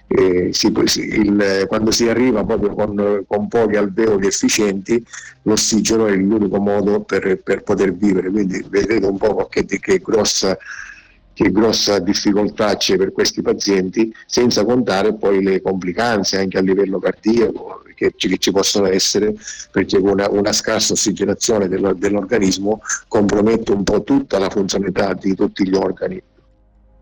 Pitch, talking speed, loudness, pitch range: 105 Hz, 145 wpm, -16 LUFS, 100-110 Hz